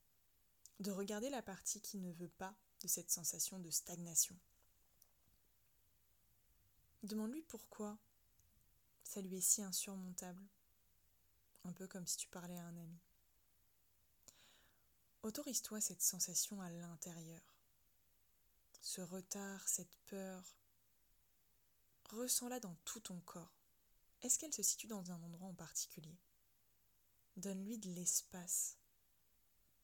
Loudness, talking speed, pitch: -43 LUFS, 110 wpm, 175 Hz